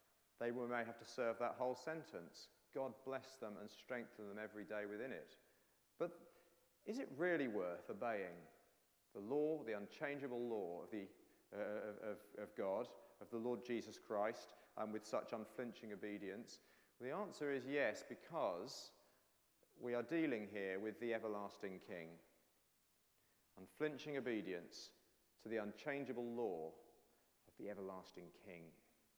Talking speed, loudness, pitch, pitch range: 140 wpm, -47 LUFS, 115 Hz, 105-130 Hz